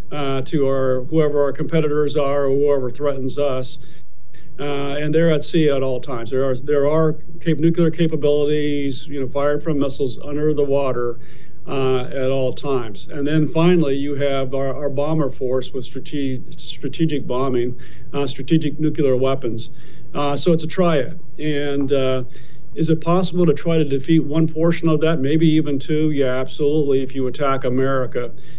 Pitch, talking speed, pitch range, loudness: 145 Hz, 170 wpm, 135-155 Hz, -20 LUFS